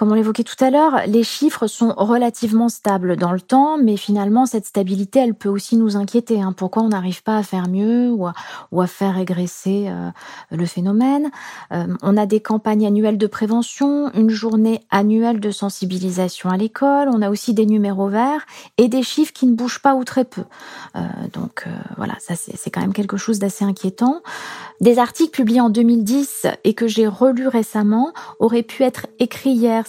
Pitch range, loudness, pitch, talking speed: 200-245 Hz, -18 LUFS, 220 Hz, 195 wpm